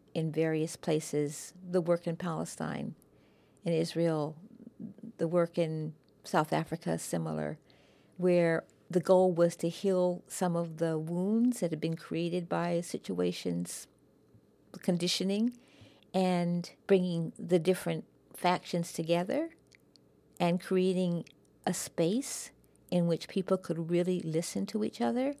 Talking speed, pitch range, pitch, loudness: 120 wpm, 165-185 Hz, 175 Hz, -32 LUFS